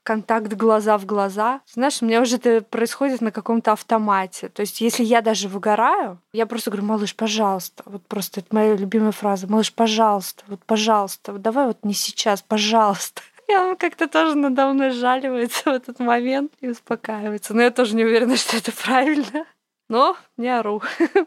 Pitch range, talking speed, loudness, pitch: 215-255 Hz, 180 wpm, -20 LUFS, 225 Hz